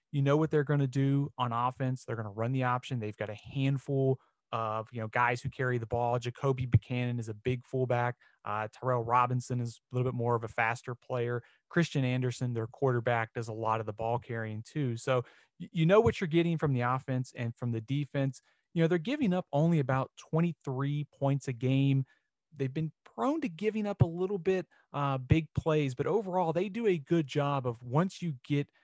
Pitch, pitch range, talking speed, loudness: 135 Hz, 120-150 Hz, 215 wpm, -32 LUFS